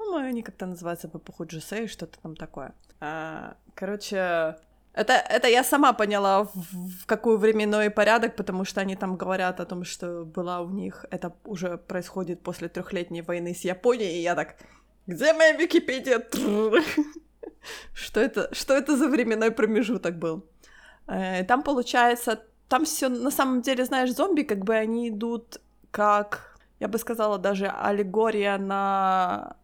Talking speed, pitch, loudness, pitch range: 150 wpm, 210 Hz, -25 LUFS, 180-240 Hz